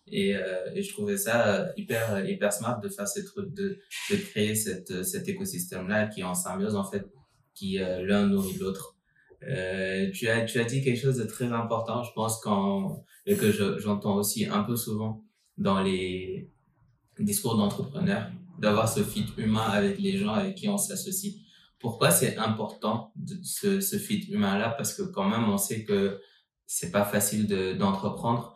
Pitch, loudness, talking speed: 125 Hz, -28 LUFS, 185 wpm